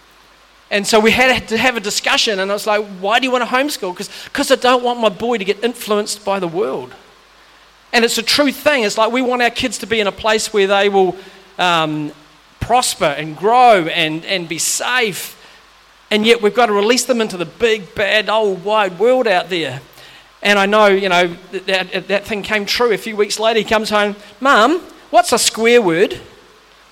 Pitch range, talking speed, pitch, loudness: 195-240 Hz, 215 wpm, 215 Hz, -15 LUFS